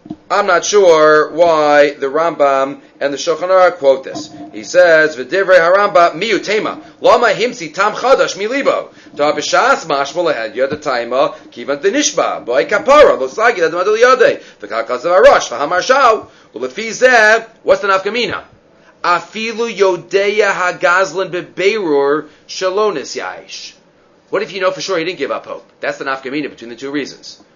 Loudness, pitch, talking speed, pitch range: -13 LUFS, 180 Hz, 170 wpm, 145-205 Hz